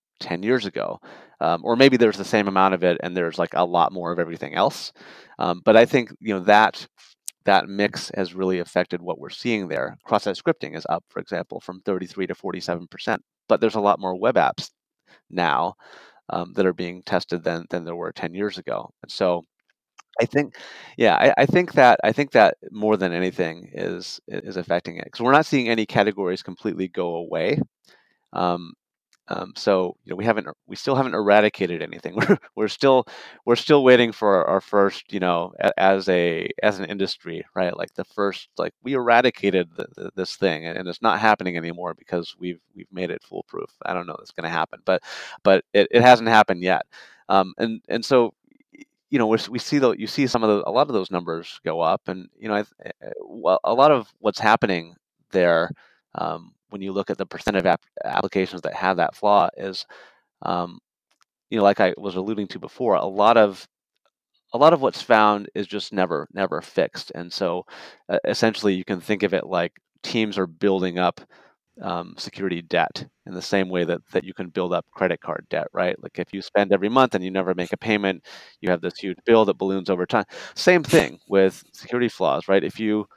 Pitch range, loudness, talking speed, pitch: 90-110 Hz, -22 LUFS, 210 wpm, 95 Hz